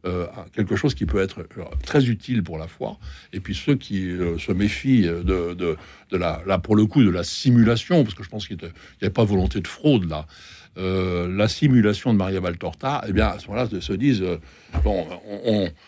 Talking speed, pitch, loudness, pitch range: 225 wpm, 95 Hz, -22 LUFS, 90-110 Hz